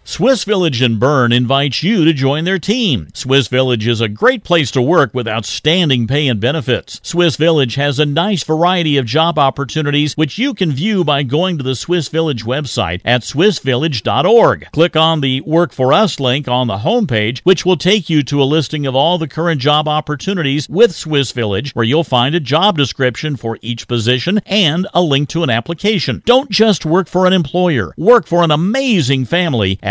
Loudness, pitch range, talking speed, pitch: -14 LUFS, 130-175 Hz, 195 wpm, 150 Hz